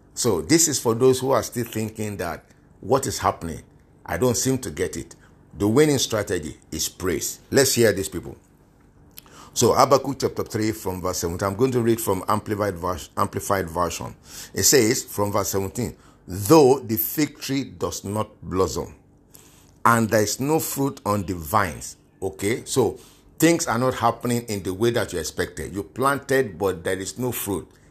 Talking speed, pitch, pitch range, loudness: 175 wpm, 110 Hz, 100-130 Hz, -22 LUFS